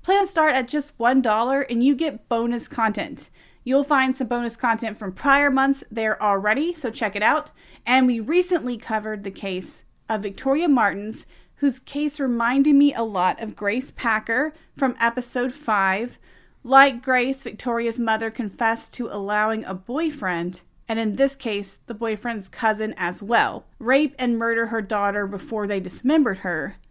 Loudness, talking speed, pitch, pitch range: -22 LUFS, 160 wpm, 235 Hz, 215-270 Hz